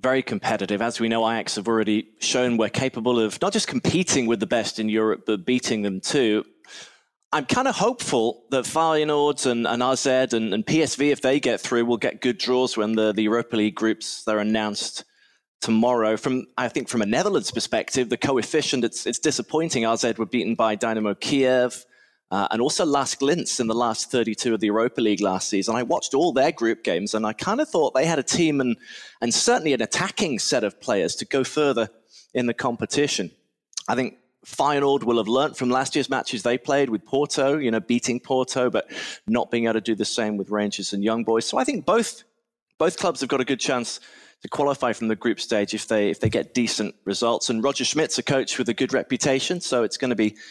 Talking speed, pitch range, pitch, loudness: 220 wpm, 110-135 Hz, 120 Hz, -23 LUFS